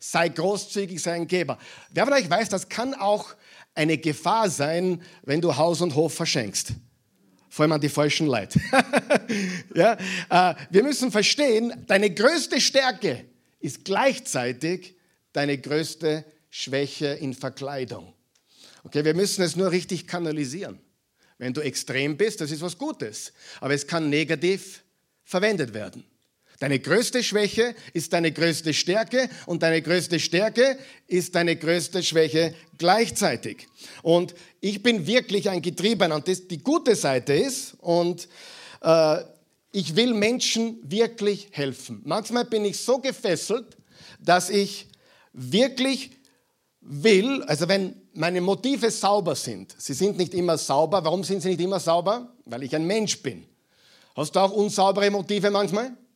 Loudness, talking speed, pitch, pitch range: -24 LUFS, 145 wpm, 180 Hz, 155-210 Hz